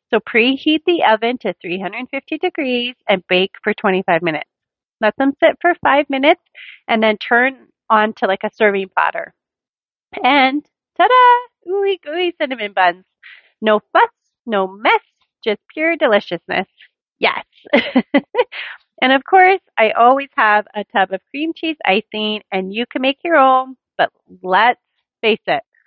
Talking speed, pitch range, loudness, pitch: 150 wpm, 210-320 Hz, -16 LUFS, 255 Hz